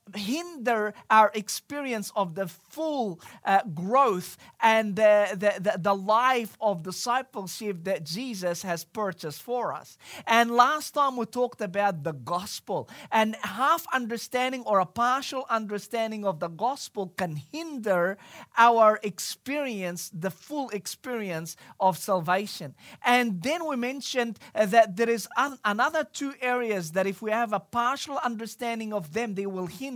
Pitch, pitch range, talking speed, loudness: 215 Hz, 195-245 Hz, 140 wpm, -27 LUFS